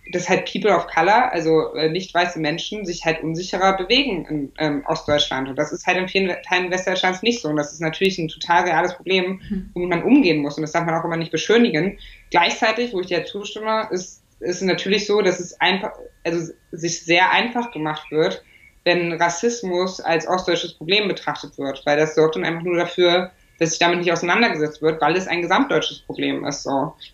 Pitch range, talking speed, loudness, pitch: 160-185 Hz, 200 wpm, -20 LUFS, 175 Hz